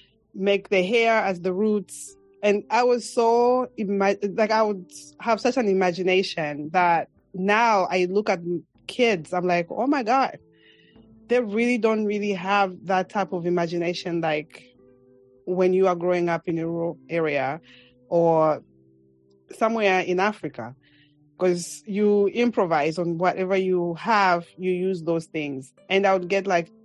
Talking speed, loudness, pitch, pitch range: 150 wpm, -23 LUFS, 185 Hz, 165-205 Hz